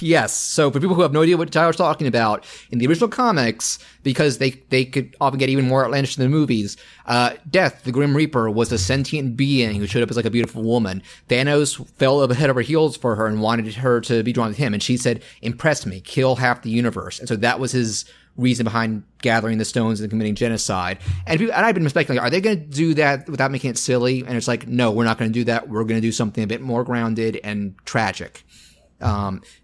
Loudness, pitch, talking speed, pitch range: -20 LUFS, 125 Hz, 245 wpm, 115-140 Hz